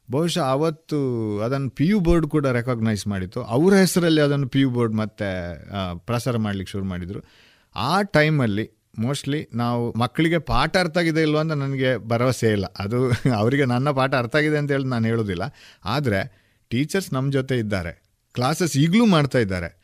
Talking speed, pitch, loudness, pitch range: 155 wpm, 125 Hz, -22 LUFS, 110-150 Hz